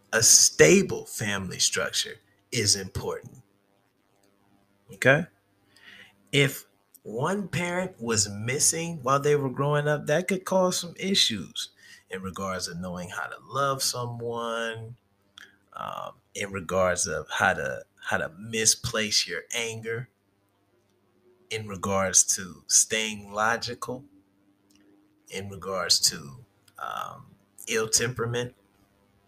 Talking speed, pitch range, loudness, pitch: 105 wpm, 100-130 Hz, -25 LUFS, 110 Hz